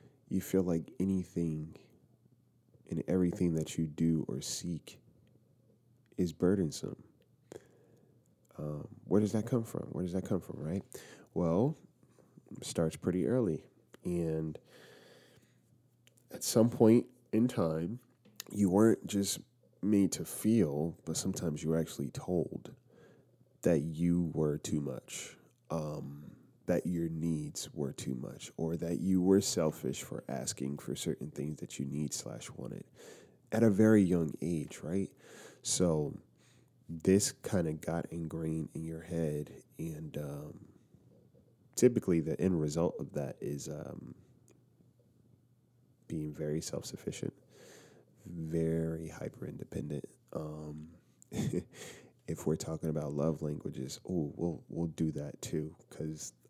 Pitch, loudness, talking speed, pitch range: 80 Hz, -34 LUFS, 125 wpm, 80-95 Hz